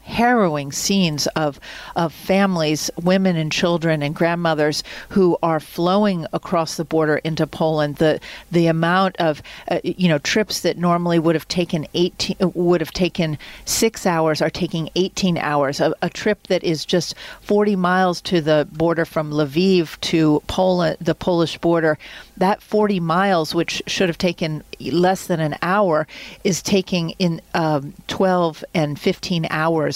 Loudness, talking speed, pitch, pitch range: -19 LUFS, 155 wpm, 170 Hz, 155-185 Hz